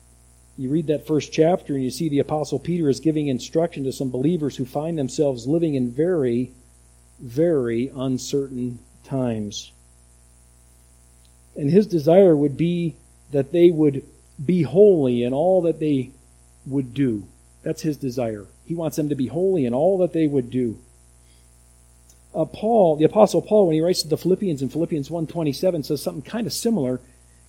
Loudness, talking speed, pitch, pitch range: -21 LUFS, 165 wpm, 140 Hz, 110-165 Hz